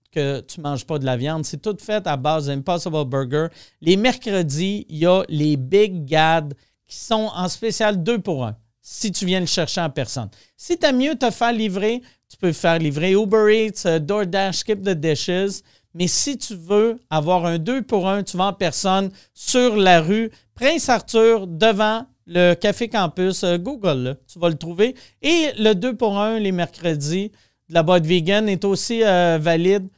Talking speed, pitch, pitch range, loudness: 195 wpm, 185 Hz, 165-215 Hz, -20 LUFS